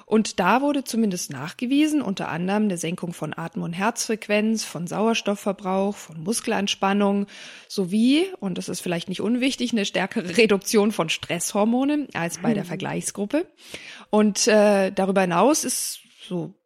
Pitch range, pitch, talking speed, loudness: 185-230 Hz, 205 Hz, 140 wpm, -23 LUFS